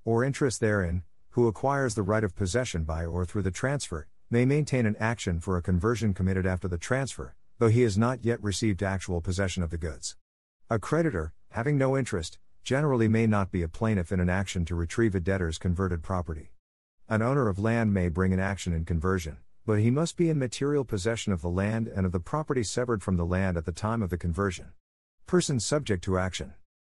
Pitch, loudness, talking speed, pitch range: 100 Hz, -28 LUFS, 210 wpm, 90-115 Hz